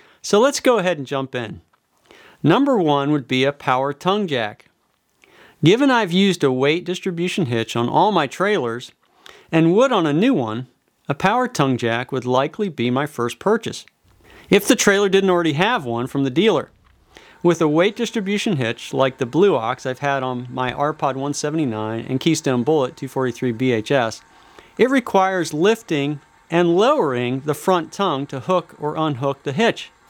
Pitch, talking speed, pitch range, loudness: 145 Hz, 170 wpm, 130-185 Hz, -19 LUFS